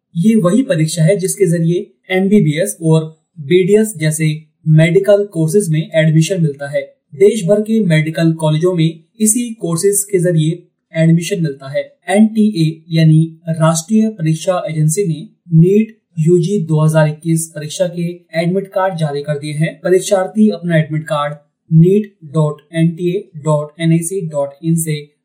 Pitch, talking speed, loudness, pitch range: 165 Hz, 130 wpm, -14 LUFS, 155-195 Hz